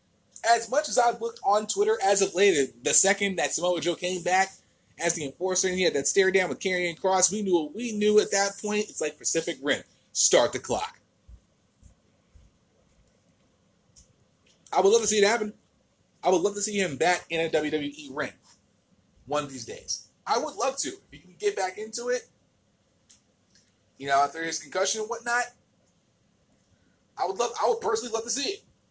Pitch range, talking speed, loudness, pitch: 165-215 Hz, 195 wpm, -26 LUFS, 195 Hz